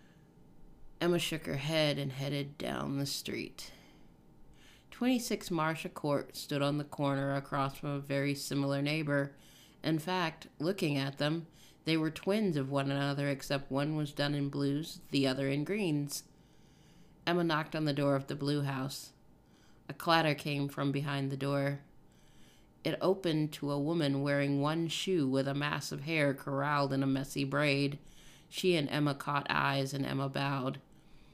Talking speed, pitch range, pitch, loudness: 165 wpm, 140-155 Hz, 145 Hz, -34 LUFS